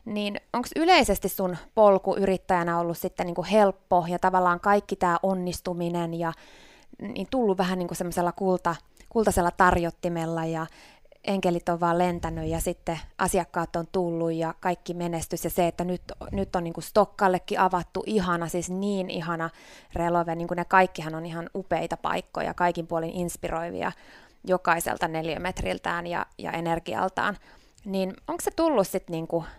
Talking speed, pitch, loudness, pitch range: 145 wpm, 180 Hz, -26 LUFS, 170-195 Hz